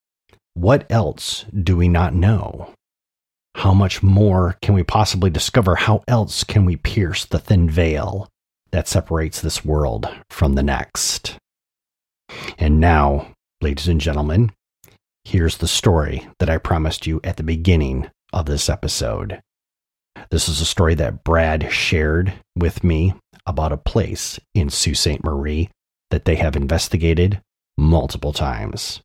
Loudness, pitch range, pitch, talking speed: -19 LUFS, 80-95 Hz, 85 Hz, 140 wpm